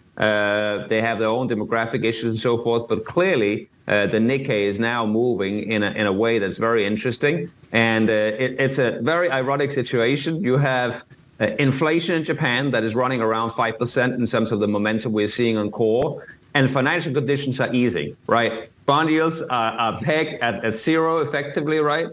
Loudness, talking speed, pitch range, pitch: -21 LUFS, 190 wpm, 110-140 Hz, 120 Hz